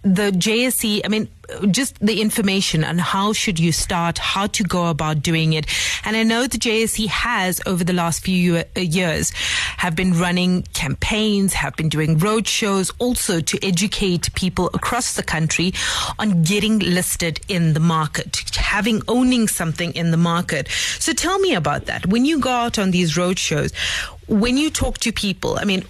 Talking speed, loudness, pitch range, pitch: 180 wpm, -19 LUFS, 170-215 Hz, 190 Hz